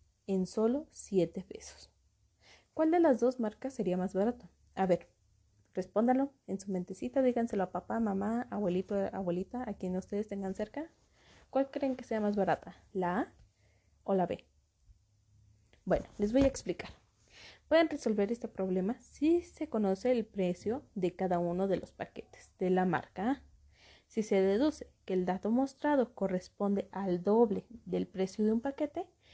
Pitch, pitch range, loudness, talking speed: 200 Hz, 185-245 Hz, -33 LUFS, 160 wpm